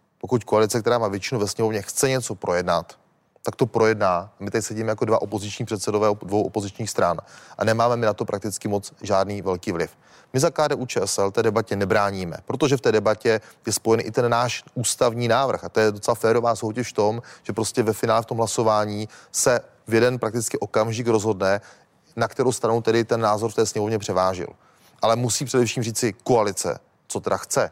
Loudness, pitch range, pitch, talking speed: -23 LUFS, 105-120 Hz, 110 Hz, 195 wpm